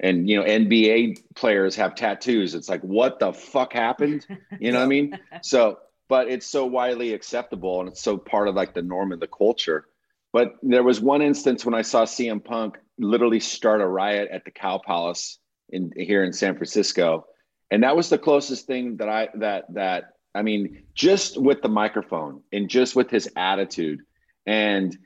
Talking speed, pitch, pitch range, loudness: 190 wpm, 115 Hz, 100-125 Hz, -22 LUFS